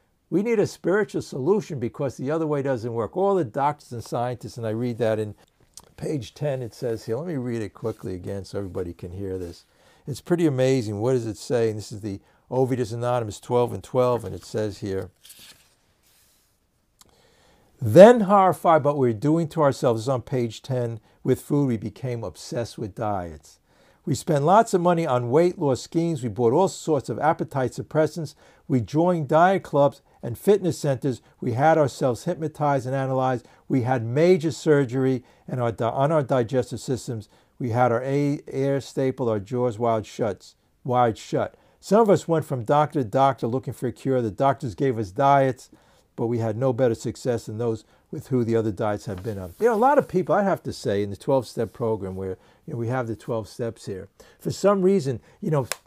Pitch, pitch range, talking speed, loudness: 125 Hz, 115-145 Hz, 200 wpm, -23 LUFS